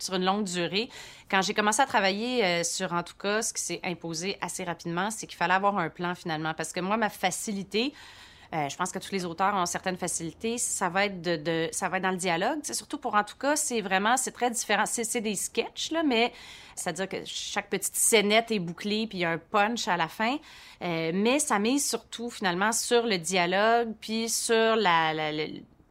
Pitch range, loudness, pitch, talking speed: 175-225 Hz, -27 LUFS, 200 Hz, 230 wpm